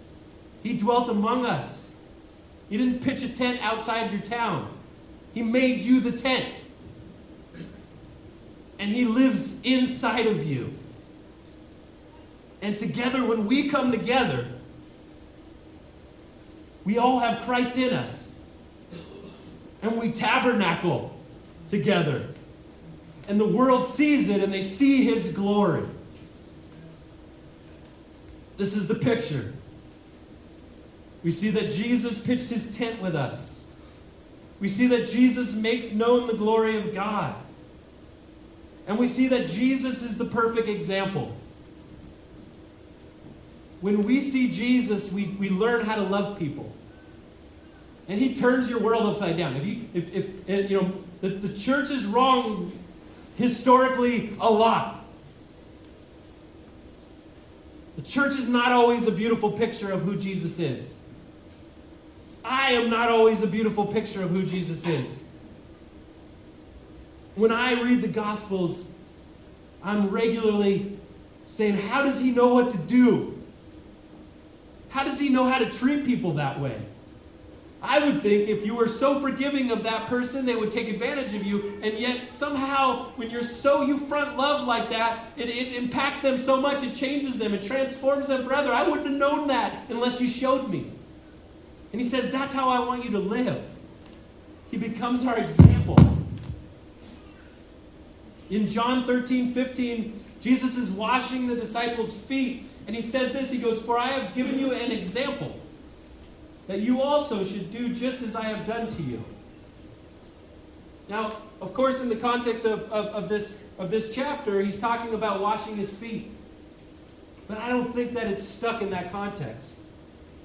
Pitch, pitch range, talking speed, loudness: 225 Hz, 195-250 Hz, 145 wpm, -25 LUFS